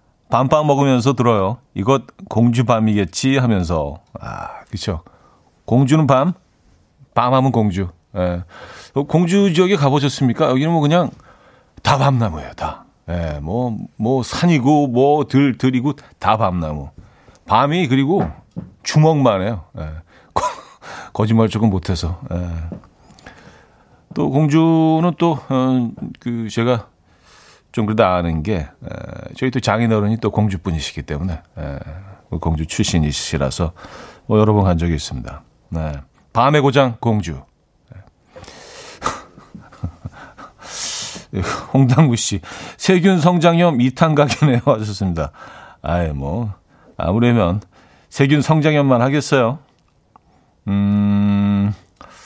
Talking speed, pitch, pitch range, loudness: 215 characters per minute, 115 Hz, 90-140 Hz, -17 LUFS